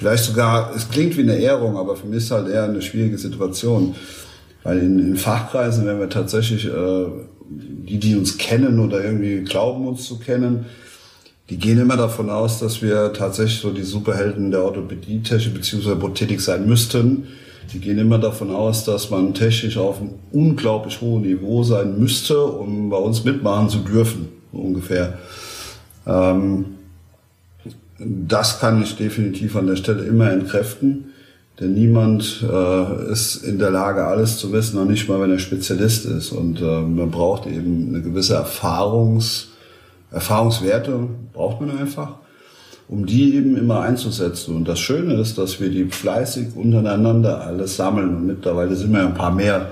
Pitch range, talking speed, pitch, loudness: 95-115 Hz, 165 wpm, 105 Hz, -19 LUFS